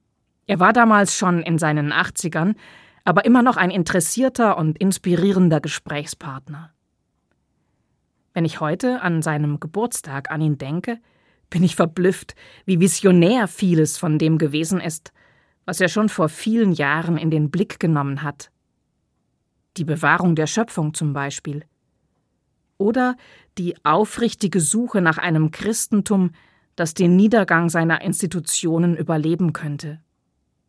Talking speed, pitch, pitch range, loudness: 125 wpm, 175 Hz, 155-195 Hz, -19 LUFS